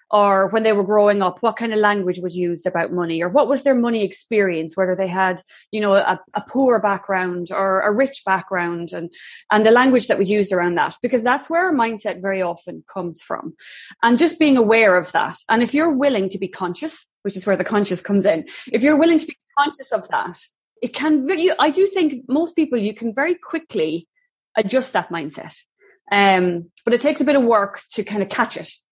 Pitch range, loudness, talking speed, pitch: 190-275 Hz, -19 LUFS, 210 wpm, 215 Hz